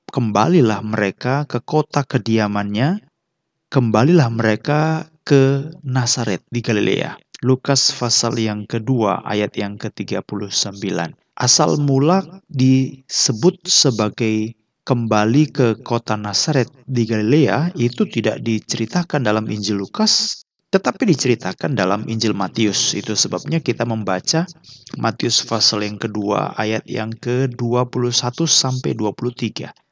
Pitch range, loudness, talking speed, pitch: 110-140 Hz, -18 LUFS, 105 wpm, 120 Hz